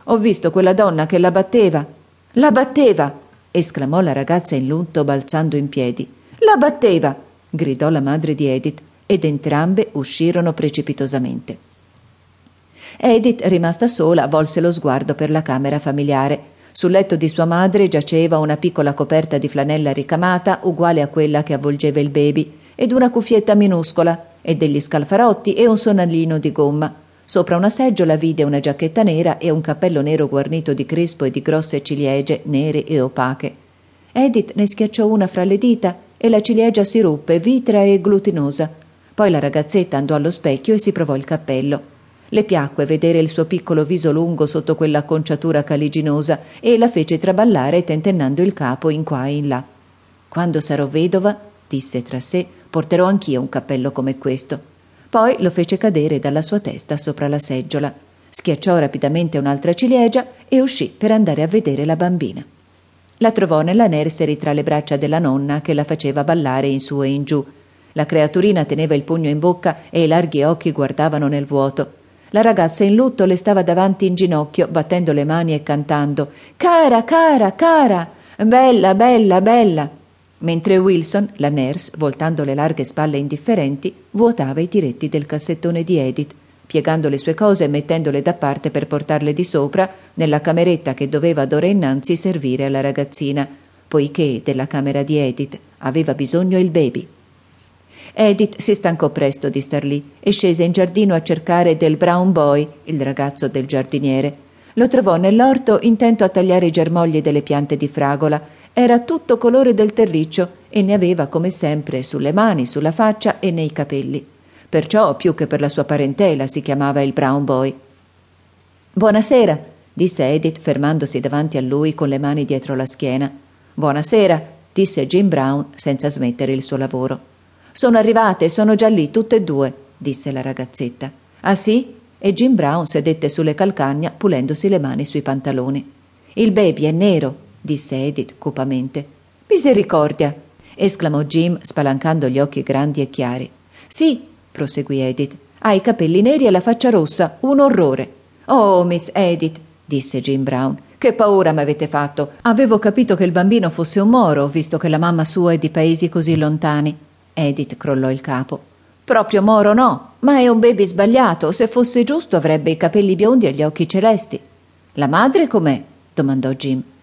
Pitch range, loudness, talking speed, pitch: 140-190 Hz, -16 LUFS, 165 wpm, 155 Hz